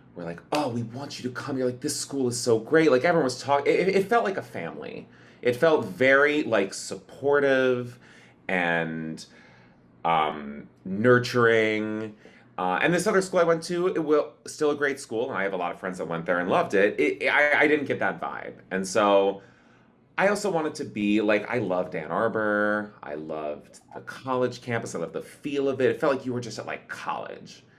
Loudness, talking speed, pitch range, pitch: -25 LUFS, 215 wpm, 105-145 Hz, 125 Hz